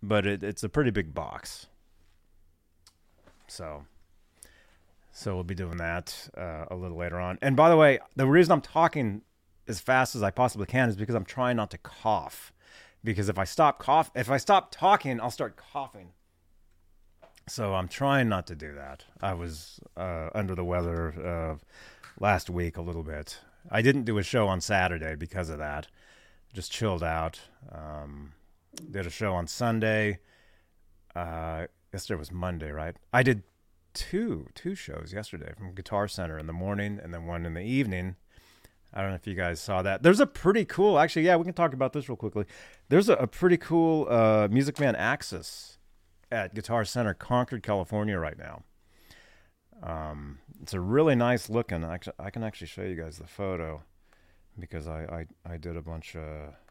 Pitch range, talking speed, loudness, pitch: 85-110 Hz, 180 wpm, -28 LUFS, 90 Hz